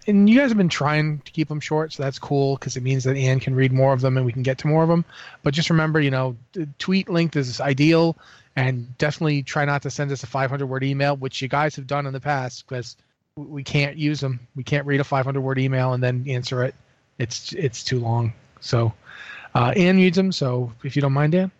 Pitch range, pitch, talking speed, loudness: 130-150 Hz, 140 Hz, 255 wpm, -22 LUFS